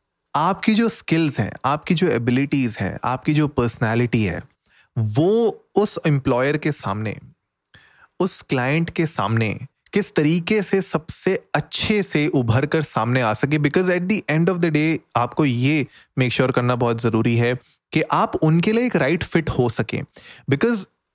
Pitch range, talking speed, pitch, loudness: 125-175 Hz, 165 wpm, 150 Hz, -20 LUFS